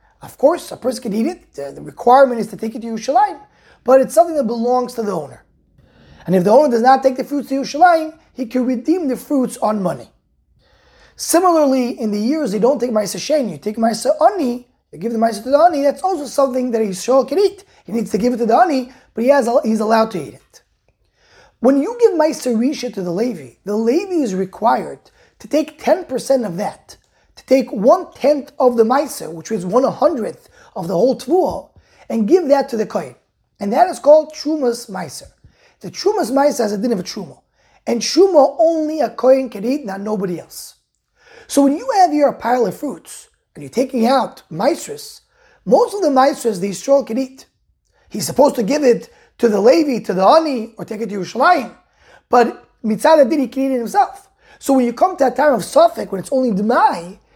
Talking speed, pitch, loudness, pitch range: 215 wpm, 260 Hz, -16 LUFS, 230-295 Hz